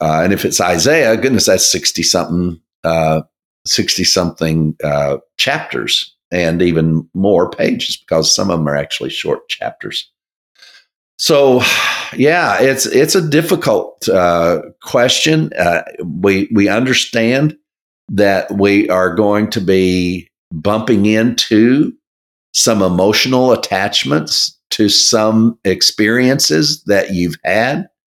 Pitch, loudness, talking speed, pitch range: 105 Hz, -13 LUFS, 115 wpm, 85-130 Hz